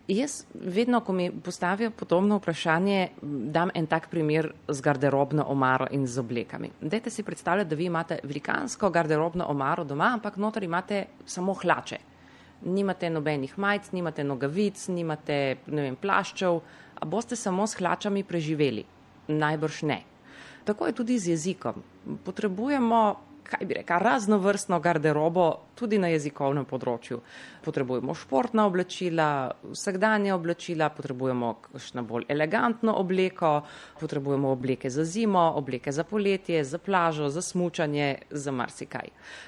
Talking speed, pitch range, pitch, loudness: 125 wpm, 145-195 Hz, 170 Hz, -28 LUFS